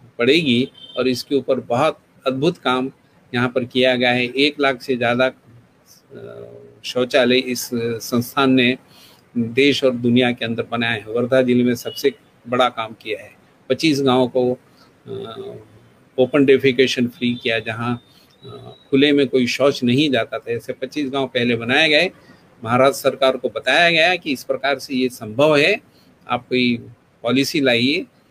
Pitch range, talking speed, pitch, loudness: 120-135 Hz, 155 wpm, 125 Hz, -18 LUFS